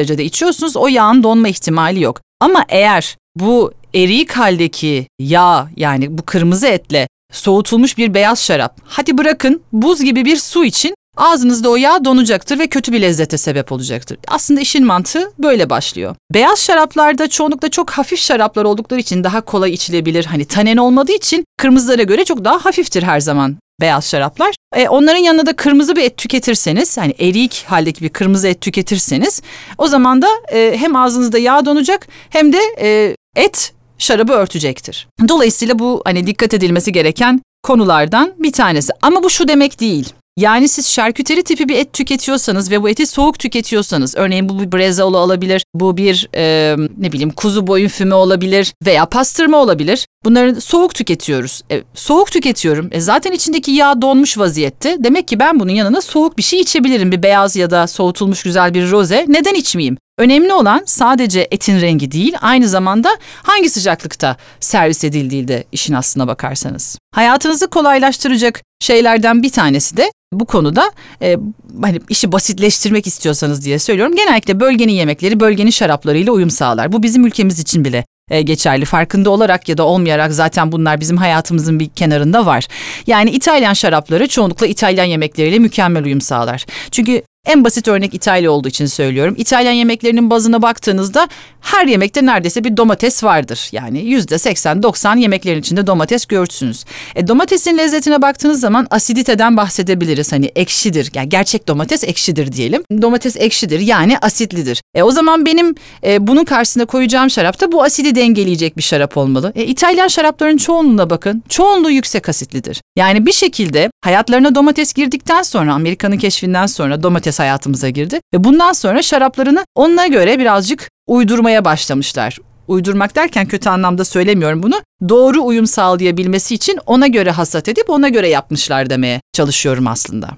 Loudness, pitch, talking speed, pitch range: -11 LUFS, 215 Hz, 160 wpm, 170-270 Hz